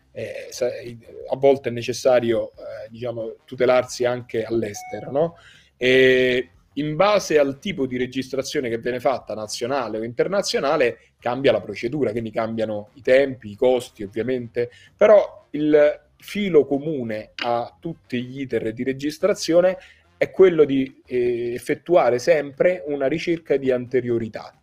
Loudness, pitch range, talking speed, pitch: -21 LUFS, 120-170 Hz, 130 wpm, 130 Hz